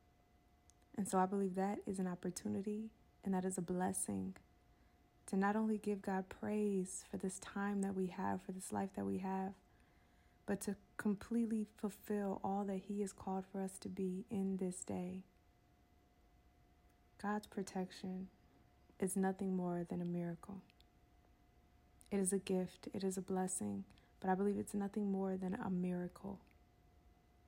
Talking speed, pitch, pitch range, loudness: 155 wpm, 190 Hz, 170-200 Hz, -42 LUFS